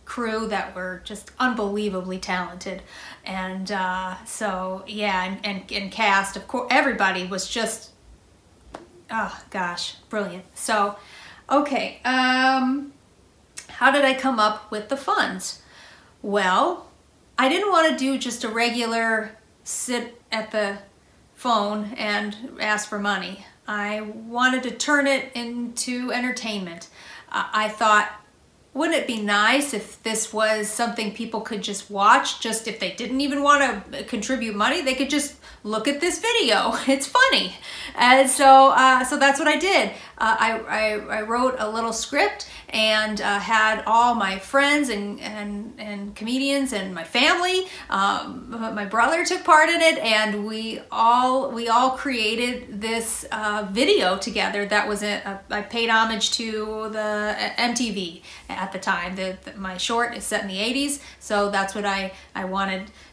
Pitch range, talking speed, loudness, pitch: 205-255 Hz, 155 wpm, -22 LUFS, 220 Hz